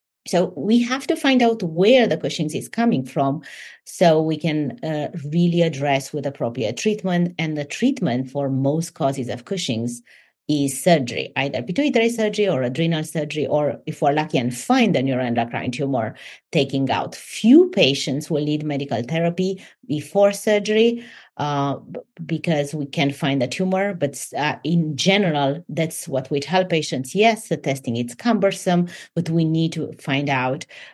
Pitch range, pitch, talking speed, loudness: 140-190 Hz, 155 Hz, 160 wpm, -21 LUFS